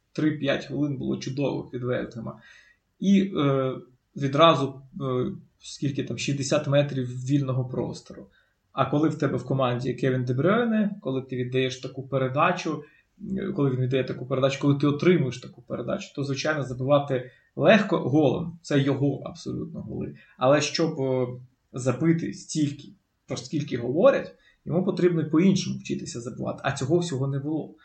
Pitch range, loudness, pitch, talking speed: 130-165 Hz, -25 LUFS, 140 Hz, 140 wpm